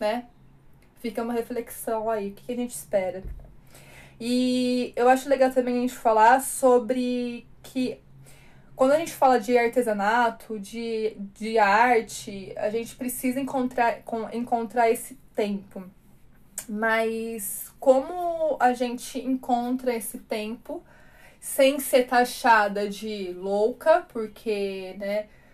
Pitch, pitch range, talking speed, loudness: 235 Hz, 220-255 Hz, 115 wpm, -25 LUFS